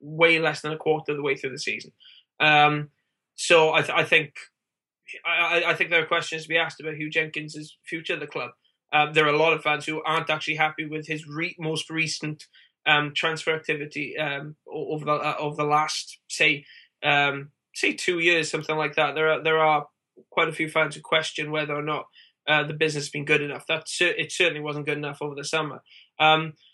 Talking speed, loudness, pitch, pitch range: 220 wpm, -24 LUFS, 155 Hz, 150-160 Hz